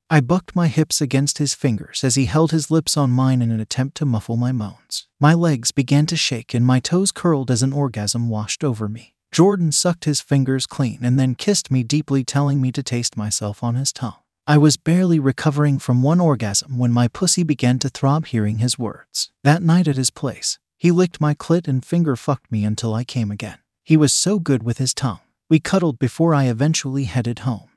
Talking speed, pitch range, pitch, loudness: 220 wpm, 120-155 Hz, 135 Hz, -19 LUFS